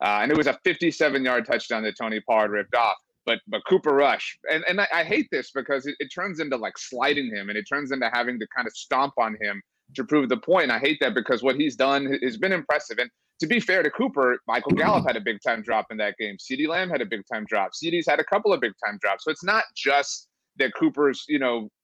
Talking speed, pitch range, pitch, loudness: 260 wpm, 115-155 Hz, 140 Hz, -24 LUFS